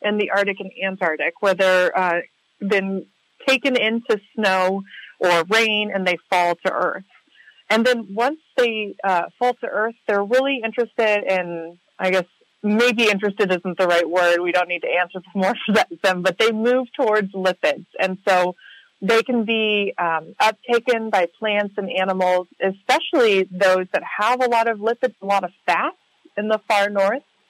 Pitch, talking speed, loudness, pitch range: 200 Hz, 170 wpm, -20 LUFS, 185-225 Hz